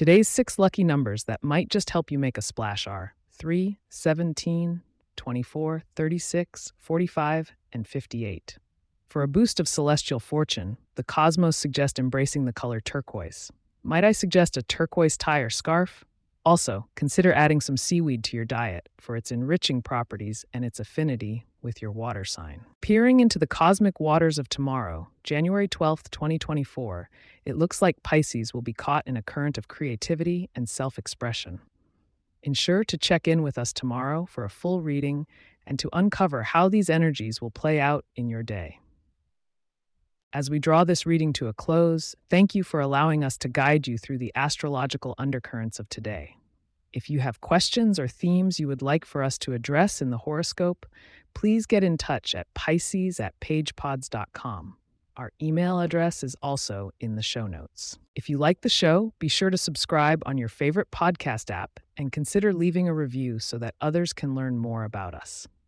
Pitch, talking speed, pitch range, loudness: 145 Hz, 175 wpm, 120-170 Hz, -26 LUFS